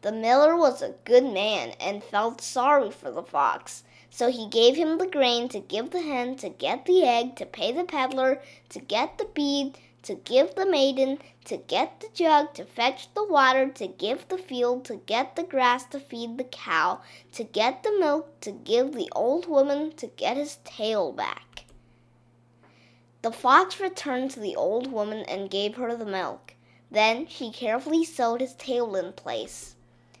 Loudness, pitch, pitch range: -25 LUFS, 255 Hz, 220-295 Hz